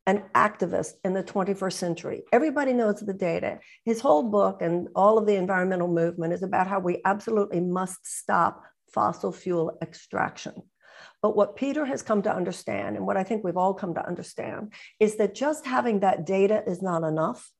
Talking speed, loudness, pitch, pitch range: 185 wpm, -26 LUFS, 195 Hz, 175-210 Hz